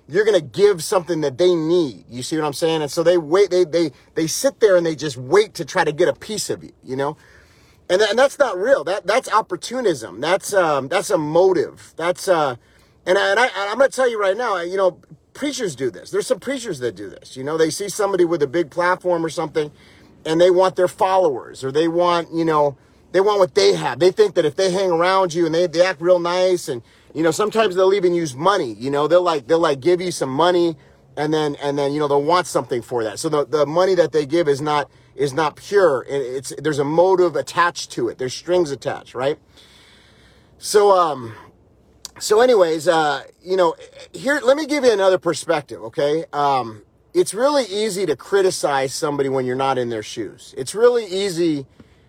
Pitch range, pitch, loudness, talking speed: 150-205 Hz, 175 Hz, -19 LUFS, 225 wpm